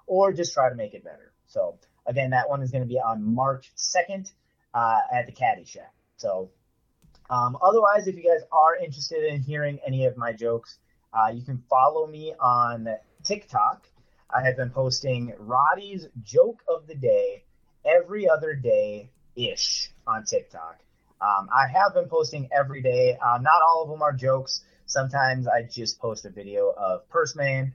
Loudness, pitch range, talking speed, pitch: -24 LUFS, 125-185 Hz, 175 wpm, 140 Hz